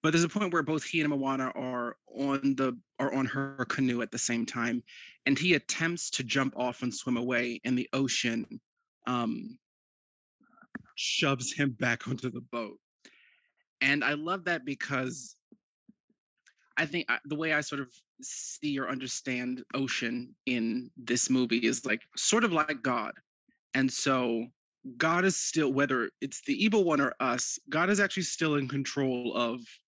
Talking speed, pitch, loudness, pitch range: 165 wpm, 135 Hz, -30 LUFS, 125-160 Hz